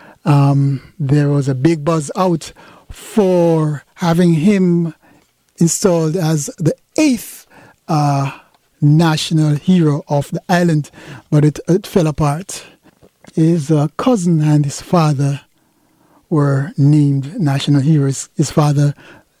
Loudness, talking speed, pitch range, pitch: -15 LUFS, 115 wpm, 145-170 Hz, 155 Hz